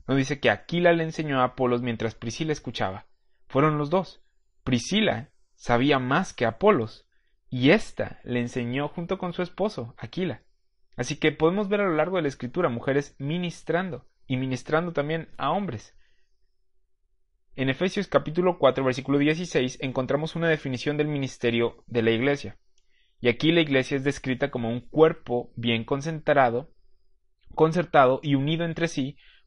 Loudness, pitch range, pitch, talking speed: -25 LUFS, 125-160 Hz, 140 Hz, 155 wpm